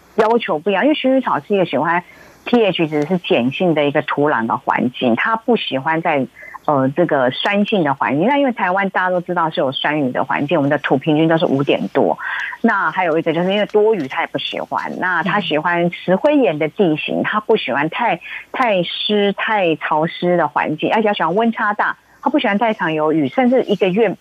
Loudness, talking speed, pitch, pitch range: -17 LUFS, 320 characters per minute, 185 Hz, 155-220 Hz